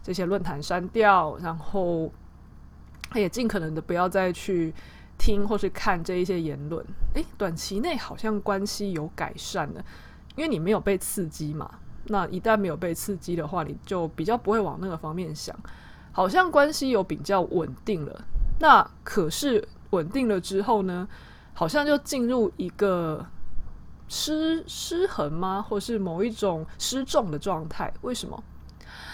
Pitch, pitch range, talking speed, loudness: 185 Hz, 160-215 Hz, 235 characters per minute, -26 LUFS